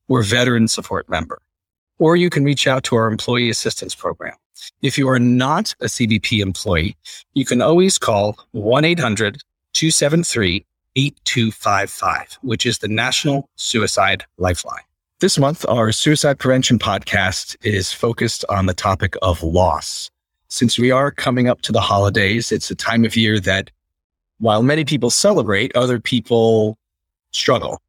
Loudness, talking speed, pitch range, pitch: -17 LUFS, 140 wpm, 100-135 Hz, 115 Hz